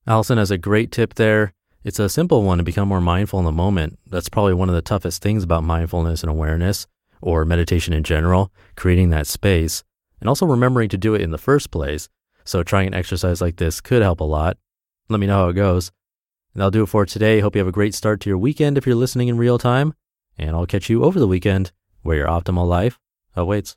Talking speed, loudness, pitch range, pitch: 235 wpm, -19 LUFS, 85-110 Hz, 95 Hz